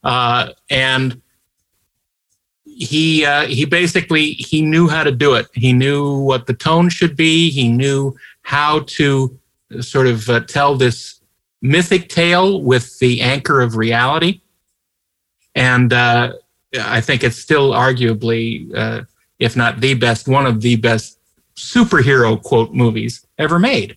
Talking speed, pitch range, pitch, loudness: 140 wpm, 120-155 Hz, 130 Hz, -14 LUFS